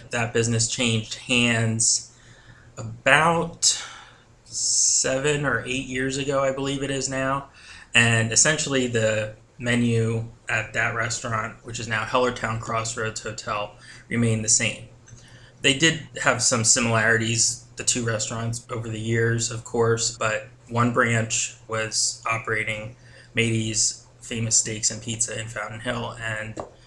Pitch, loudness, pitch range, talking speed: 115 Hz, -22 LUFS, 110-125 Hz, 130 wpm